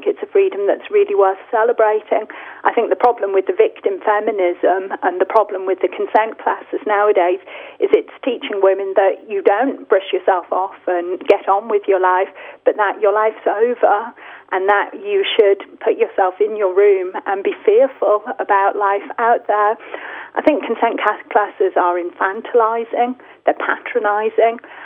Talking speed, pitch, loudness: 165 wpm, 225 Hz, -17 LUFS